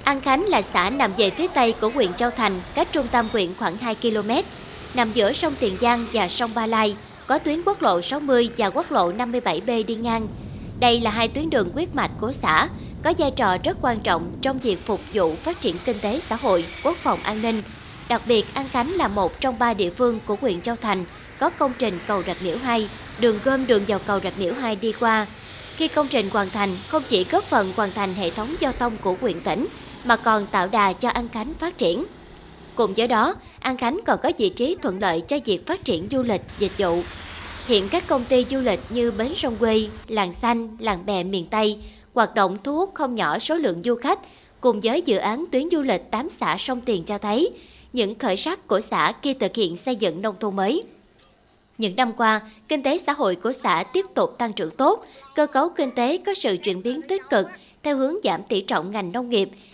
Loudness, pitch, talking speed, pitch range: -22 LUFS, 235 Hz, 230 wpm, 210-280 Hz